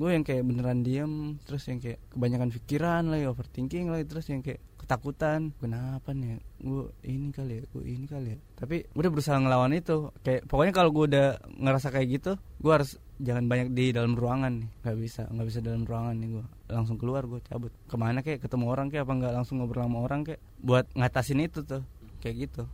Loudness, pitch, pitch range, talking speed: -30 LUFS, 130 Hz, 120-140 Hz, 210 wpm